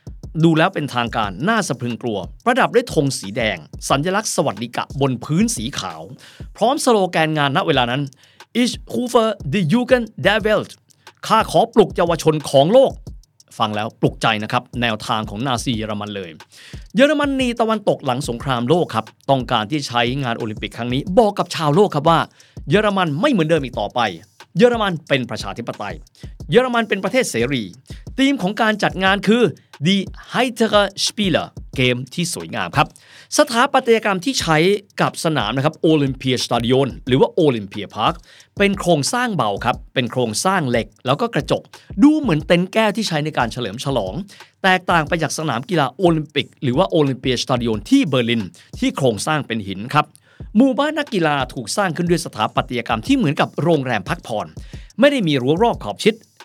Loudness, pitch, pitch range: -18 LUFS, 155 Hz, 125-210 Hz